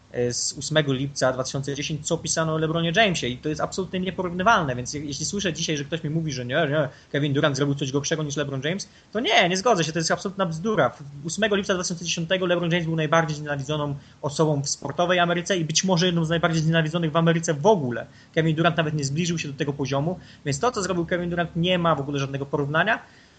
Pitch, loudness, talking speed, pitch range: 160 Hz, -24 LUFS, 220 wpm, 145-175 Hz